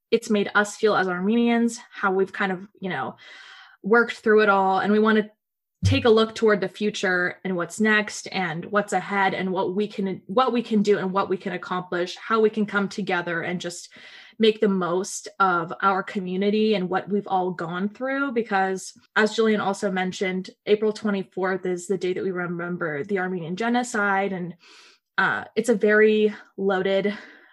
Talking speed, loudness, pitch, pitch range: 185 wpm, -23 LUFS, 200 Hz, 185-215 Hz